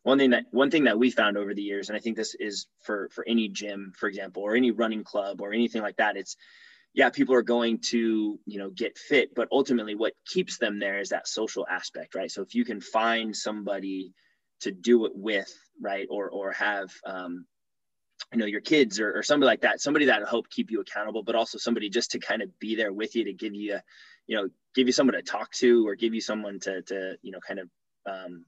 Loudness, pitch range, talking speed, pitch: -27 LUFS, 100-120 Hz, 240 wpm, 110 Hz